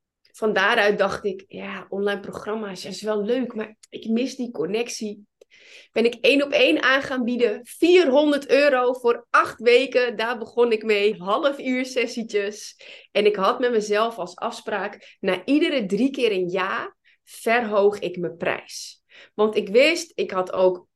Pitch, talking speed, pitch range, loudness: 230 Hz, 165 wpm, 205-255 Hz, -22 LUFS